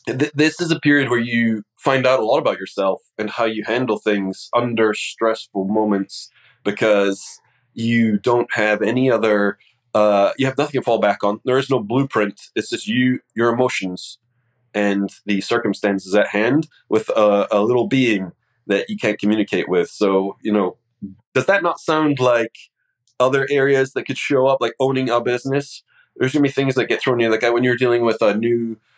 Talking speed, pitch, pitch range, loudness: 190 wpm, 115 Hz, 105-130 Hz, -19 LUFS